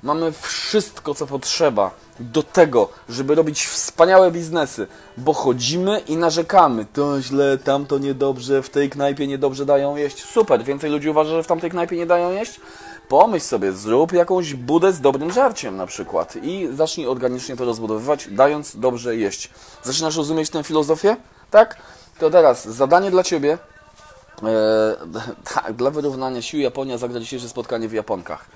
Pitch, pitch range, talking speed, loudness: 145 Hz, 130-165 Hz, 155 wpm, -19 LUFS